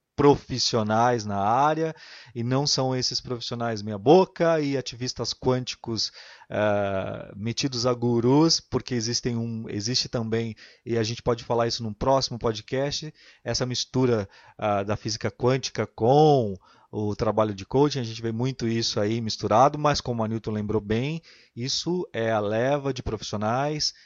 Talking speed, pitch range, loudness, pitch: 150 wpm, 110-135 Hz, -25 LUFS, 120 Hz